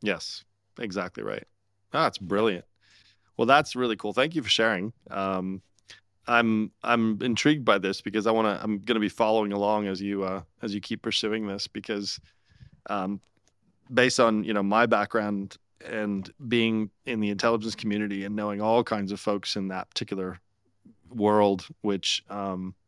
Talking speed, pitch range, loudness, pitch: 160 wpm, 100-115 Hz, -27 LUFS, 105 Hz